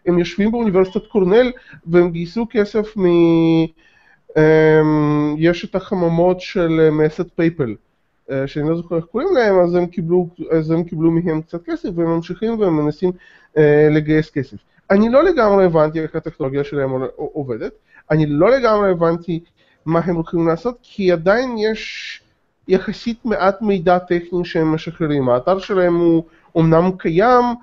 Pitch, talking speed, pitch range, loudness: 175 Hz, 140 wpm, 160-195 Hz, -17 LUFS